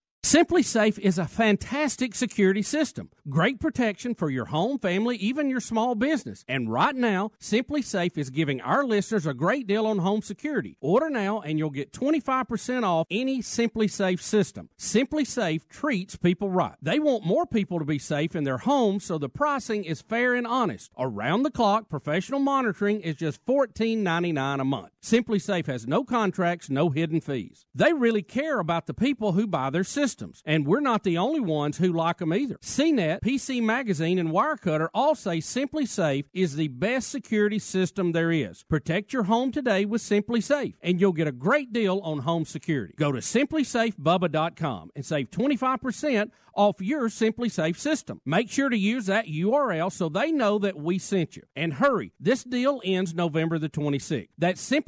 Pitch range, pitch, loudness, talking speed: 165-245 Hz, 205 Hz, -26 LUFS, 185 wpm